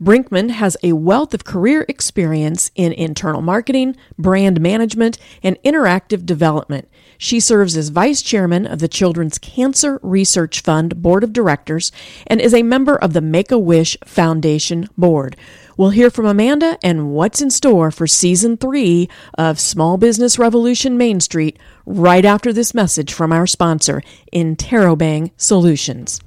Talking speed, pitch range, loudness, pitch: 150 wpm, 165-230 Hz, -14 LUFS, 180 Hz